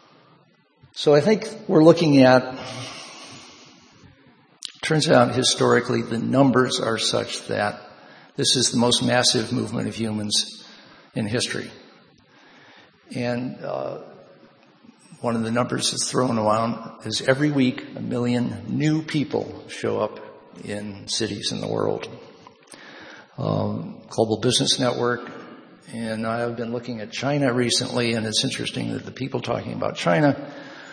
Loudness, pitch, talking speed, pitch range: -22 LUFS, 125 Hz, 130 wpm, 115-130 Hz